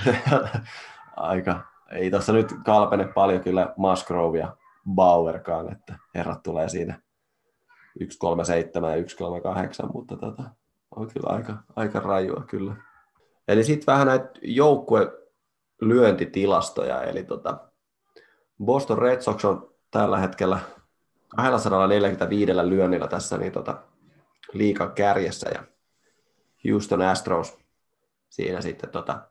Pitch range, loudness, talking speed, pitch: 90-125 Hz, -24 LUFS, 105 wpm, 100 Hz